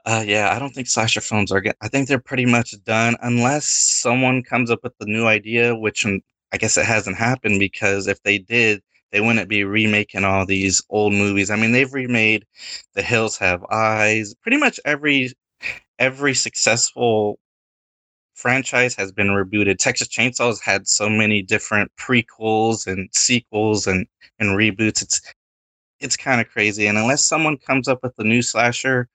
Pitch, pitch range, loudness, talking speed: 110 Hz, 105-120 Hz, -18 LUFS, 175 wpm